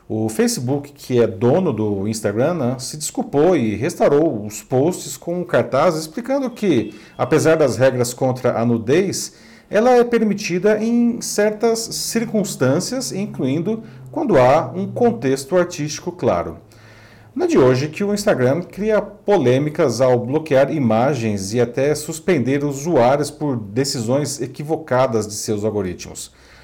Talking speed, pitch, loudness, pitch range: 135 wpm, 145 Hz, -18 LUFS, 120-185 Hz